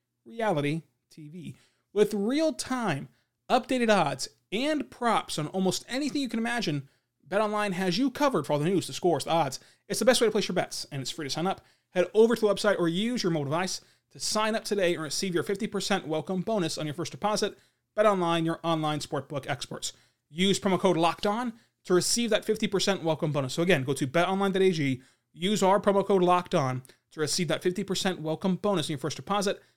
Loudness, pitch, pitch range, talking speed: -28 LUFS, 185 Hz, 155-210 Hz, 210 wpm